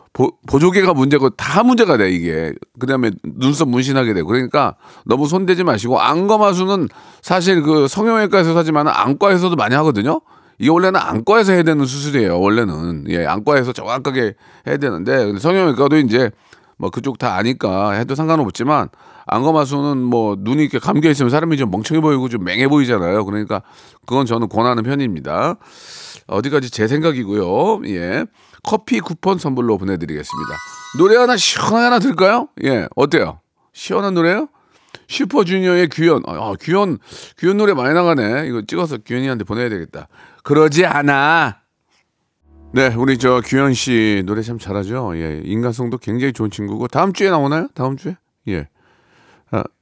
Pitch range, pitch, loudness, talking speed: 115-175 Hz, 140 Hz, -16 LUFS, 365 characters per minute